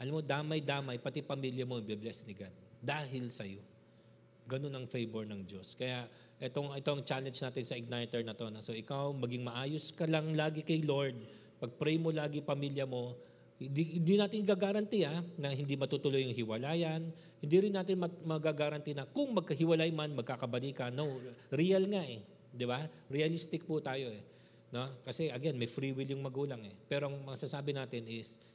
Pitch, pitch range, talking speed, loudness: 140 Hz, 120-155 Hz, 175 wpm, -37 LUFS